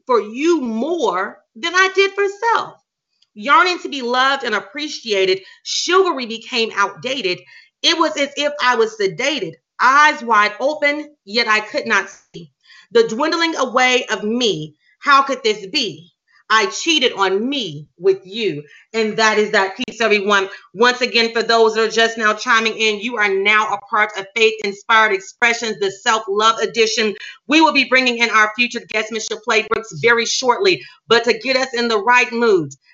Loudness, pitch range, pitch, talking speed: -16 LUFS, 215-280 Hz, 230 Hz, 175 wpm